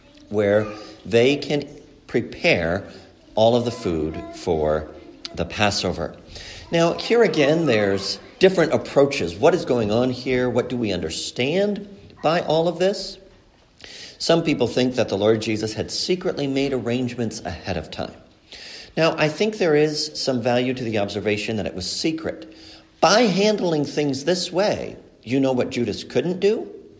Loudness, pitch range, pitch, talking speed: -21 LUFS, 105-165 Hz, 125 Hz, 155 wpm